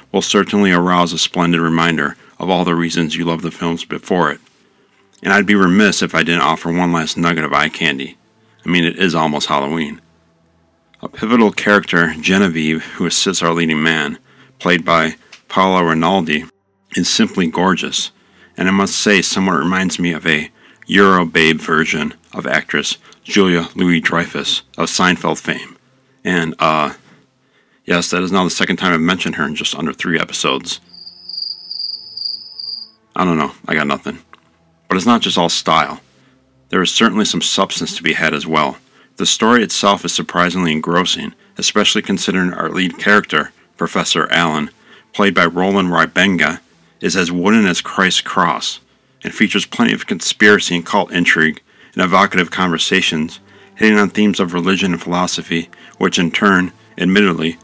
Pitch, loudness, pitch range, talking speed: 85 Hz, -15 LUFS, 80-95 Hz, 160 wpm